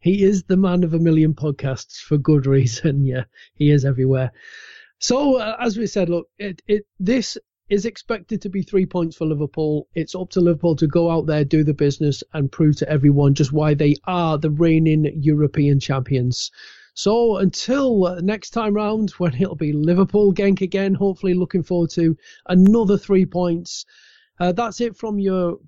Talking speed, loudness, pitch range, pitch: 180 wpm, -19 LUFS, 150-200 Hz, 175 Hz